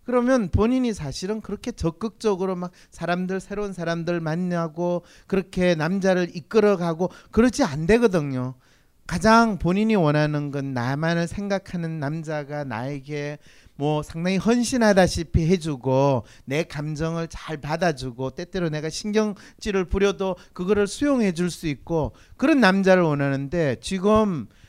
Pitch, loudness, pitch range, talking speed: 175 Hz, -23 LUFS, 150-200 Hz, 305 characters per minute